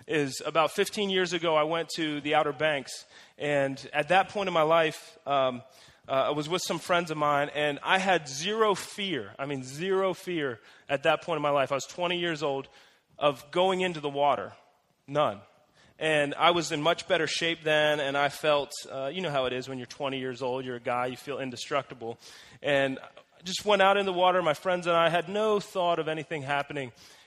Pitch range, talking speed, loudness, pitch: 140-175 Hz, 220 wpm, -28 LUFS, 155 Hz